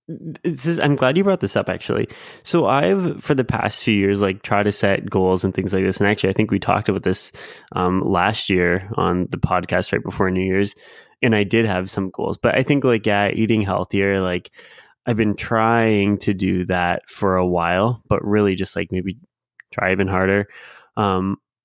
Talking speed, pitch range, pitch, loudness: 210 wpm, 95-115 Hz, 100 Hz, -19 LUFS